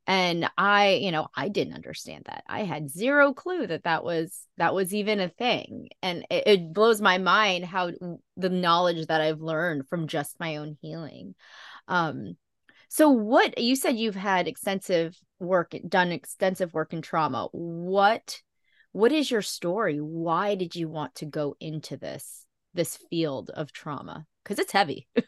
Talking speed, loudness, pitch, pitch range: 170 wpm, -26 LUFS, 180 Hz, 160-205 Hz